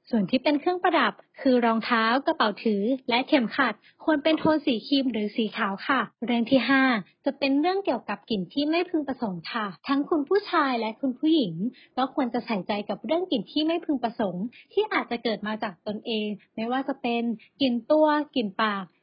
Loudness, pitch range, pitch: -26 LUFS, 220-295 Hz, 250 Hz